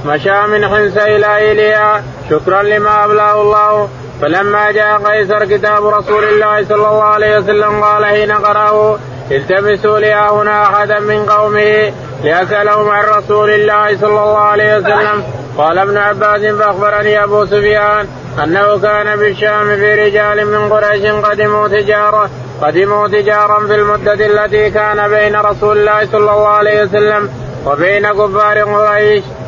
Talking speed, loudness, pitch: 135 wpm, -10 LUFS, 210 Hz